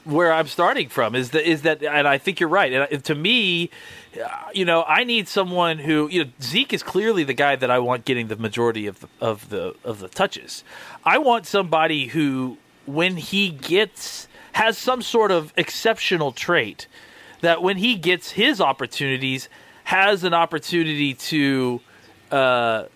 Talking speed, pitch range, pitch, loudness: 175 wpm, 135-195 Hz, 160 Hz, -20 LUFS